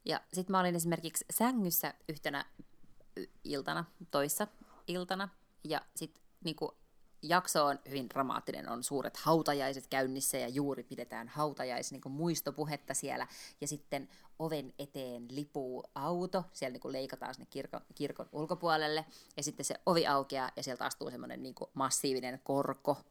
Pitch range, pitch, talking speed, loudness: 135-170 Hz, 145 Hz, 140 wpm, -37 LUFS